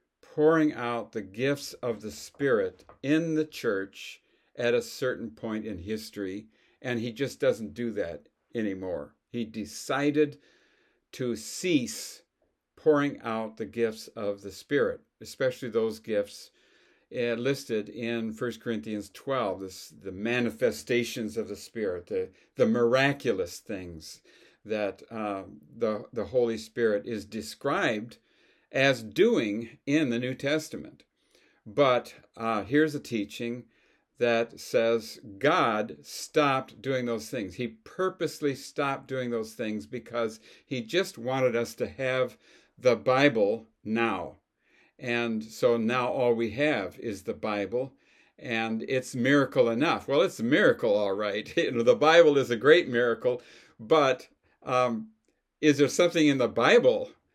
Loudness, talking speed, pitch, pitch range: -28 LUFS, 135 wpm, 120 Hz, 110-140 Hz